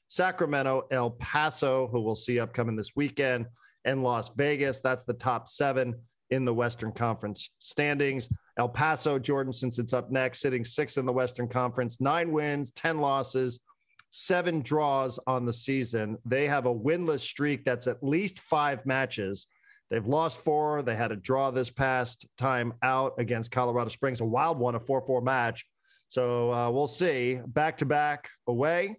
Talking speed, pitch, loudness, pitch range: 170 wpm, 130 Hz, -29 LUFS, 120-145 Hz